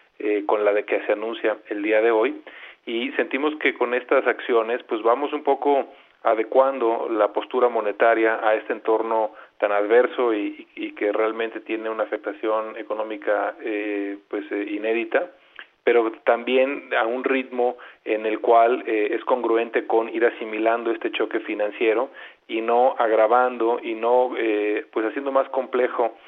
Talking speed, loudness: 160 wpm, -22 LUFS